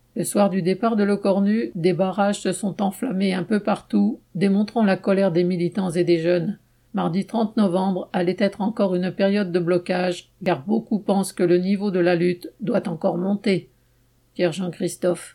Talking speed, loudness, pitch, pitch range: 185 wpm, -22 LUFS, 190 Hz, 180-200 Hz